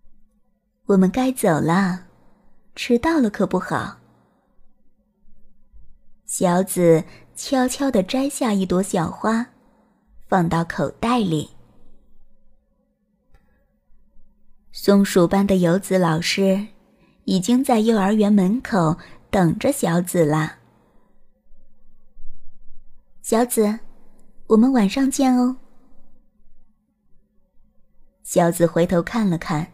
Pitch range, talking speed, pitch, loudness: 180-235 Hz, 125 characters per minute, 205 Hz, -19 LUFS